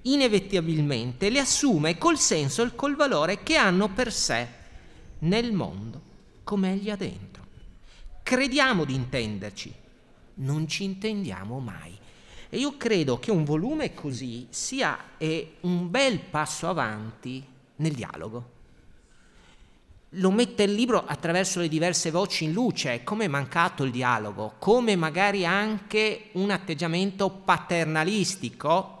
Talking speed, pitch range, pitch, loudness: 125 wpm, 130-210 Hz, 175 Hz, -26 LUFS